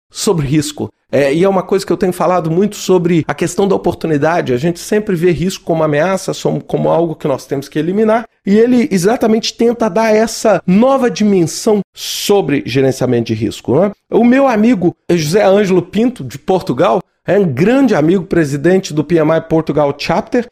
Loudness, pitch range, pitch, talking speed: -13 LUFS, 160-215 Hz, 185 Hz, 180 wpm